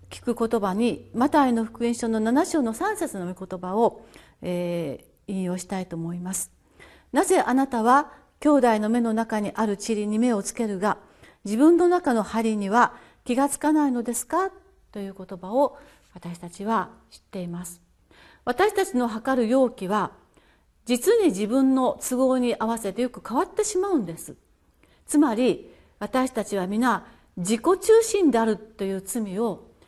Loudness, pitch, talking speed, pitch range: -24 LUFS, 230 Hz, 285 characters per minute, 205-275 Hz